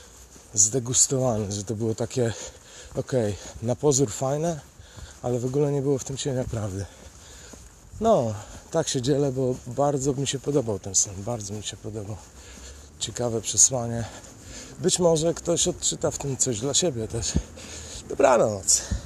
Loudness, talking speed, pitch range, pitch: -24 LUFS, 145 wpm, 100-140 Hz, 115 Hz